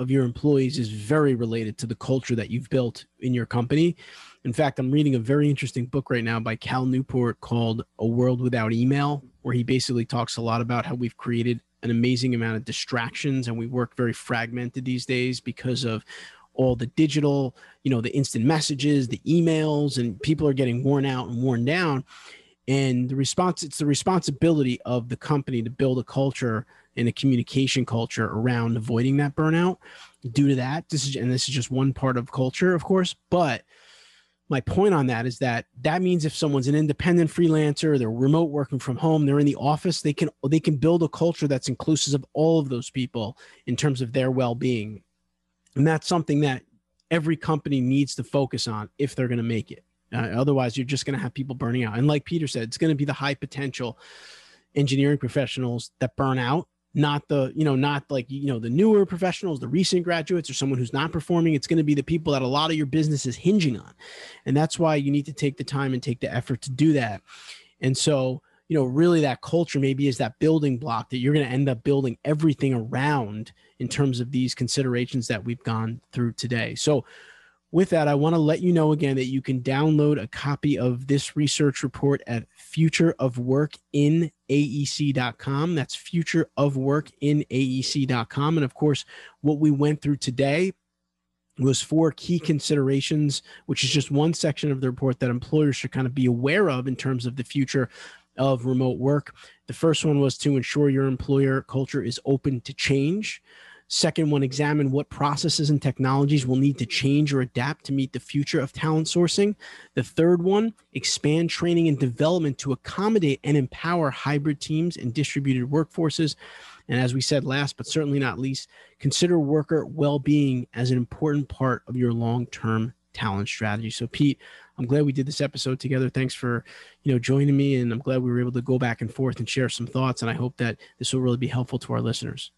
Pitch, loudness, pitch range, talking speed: 135 Hz, -24 LUFS, 125-150 Hz, 205 wpm